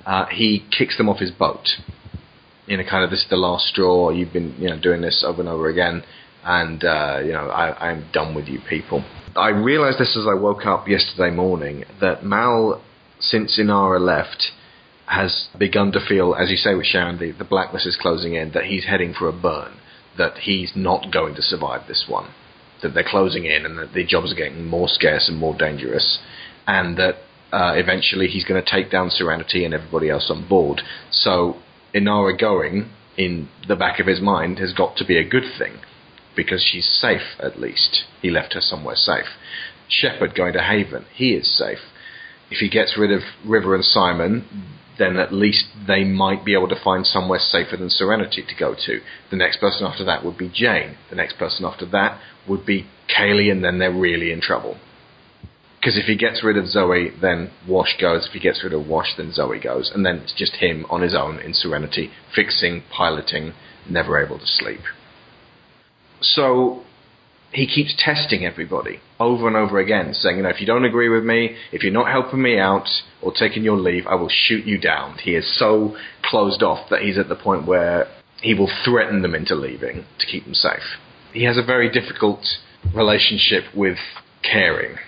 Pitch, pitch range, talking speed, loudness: 95 Hz, 90-110 Hz, 200 wpm, -19 LUFS